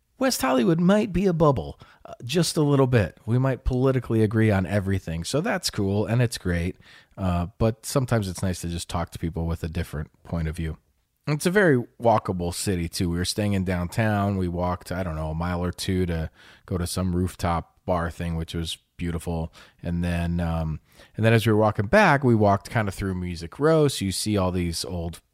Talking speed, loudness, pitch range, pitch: 220 wpm, -24 LUFS, 85-115 Hz, 95 Hz